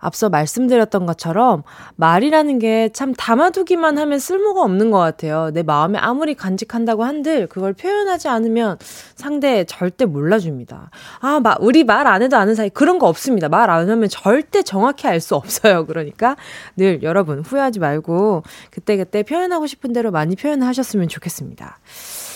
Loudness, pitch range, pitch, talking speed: -16 LUFS, 180-275 Hz, 220 Hz, 365 characters per minute